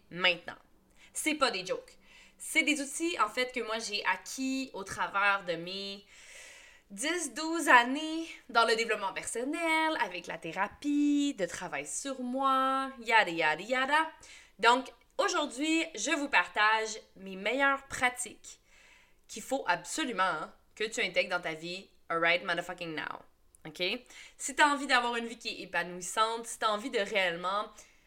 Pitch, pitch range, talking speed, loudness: 235 Hz, 185-285 Hz, 155 wpm, -30 LUFS